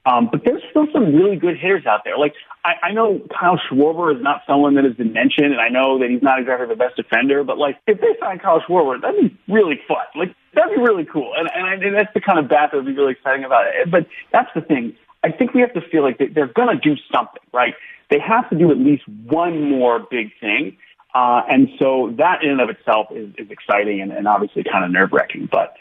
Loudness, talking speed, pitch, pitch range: -17 LUFS, 260 wpm, 150 Hz, 130-215 Hz